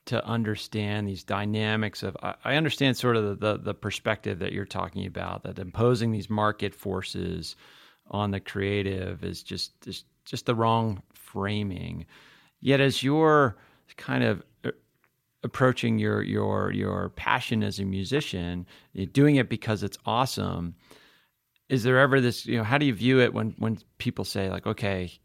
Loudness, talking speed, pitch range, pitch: -27 LUFS, 160 wpm, 100-120 Hz, 105 Hz